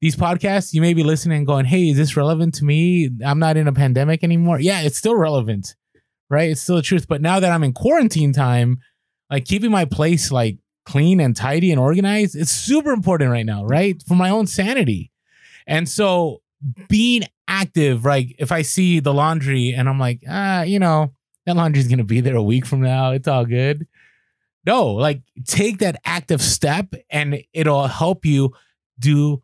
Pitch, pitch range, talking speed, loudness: 155 Hz, 135-180 Hz, 195 wpm, -18 LUFS